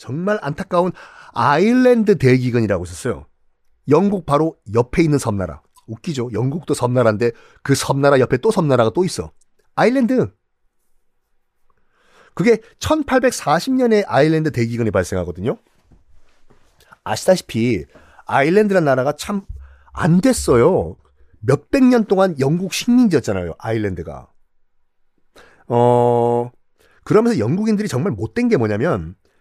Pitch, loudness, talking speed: 135 Hz, -17 LUFS, 270 characters per minute